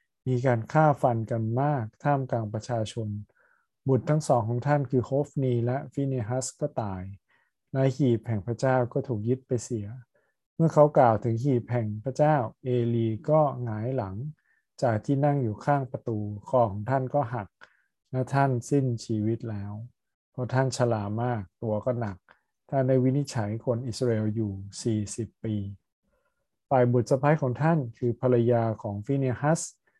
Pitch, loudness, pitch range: 125 Hz, -27 LUFS, 115-135 Hz